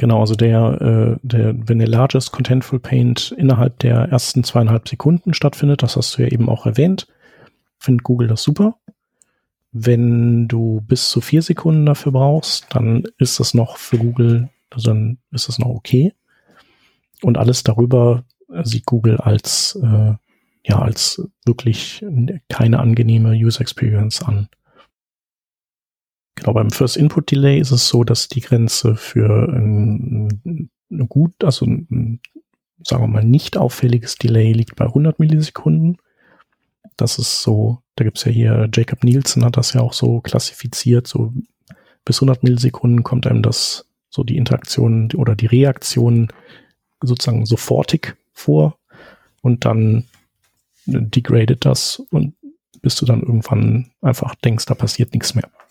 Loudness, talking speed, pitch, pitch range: -16 LUFS, 145 wpm, 120 Hz, 115-135 Hz